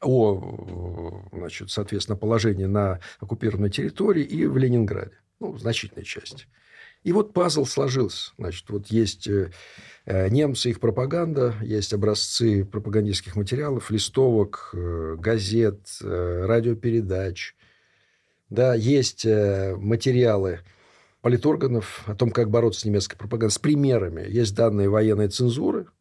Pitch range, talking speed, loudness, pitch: 100-120 Hz, 110 wpm, -24 LUFS, 110 Hz